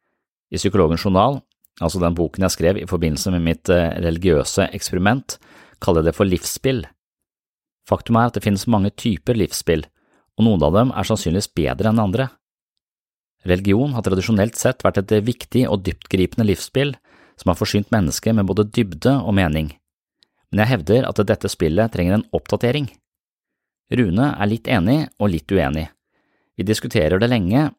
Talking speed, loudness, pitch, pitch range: 160 wpm, -19 LUFS, 100 Hz, 90-115 Hz